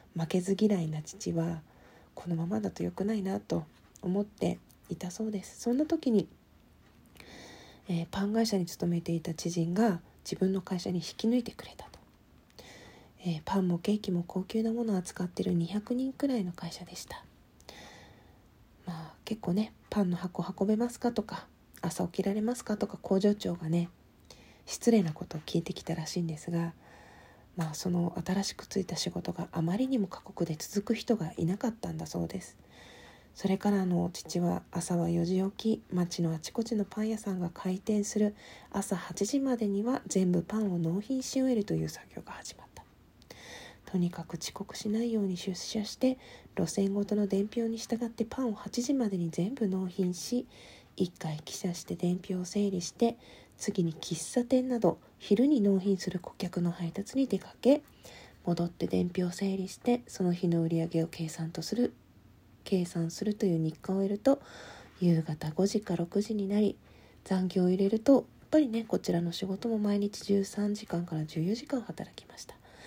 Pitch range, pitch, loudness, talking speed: 170-215 Hz, 190 Hz, -32 LUFS, 315 characters per minute